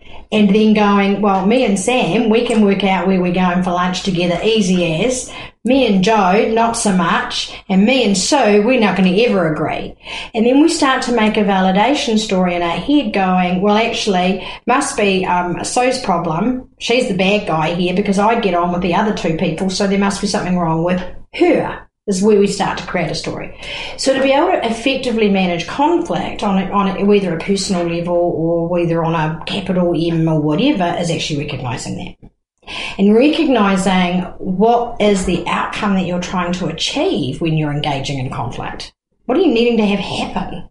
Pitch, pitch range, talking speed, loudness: 195 Hz, 175-225 Hz, 200 wpm, -15 LUFS